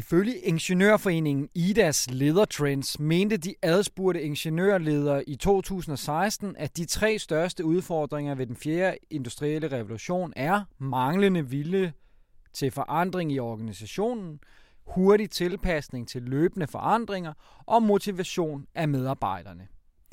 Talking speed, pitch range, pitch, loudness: 105 wpm, 140-190 Hz, 160 Hz, -27 LUFS